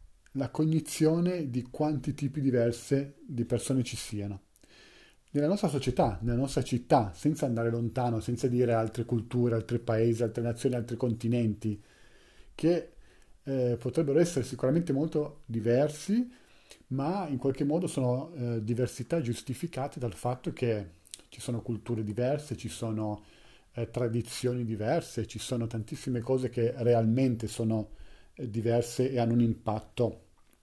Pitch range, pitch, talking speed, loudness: 115-140 Hz, 120 Hz, 135 wpm, -31 LUFS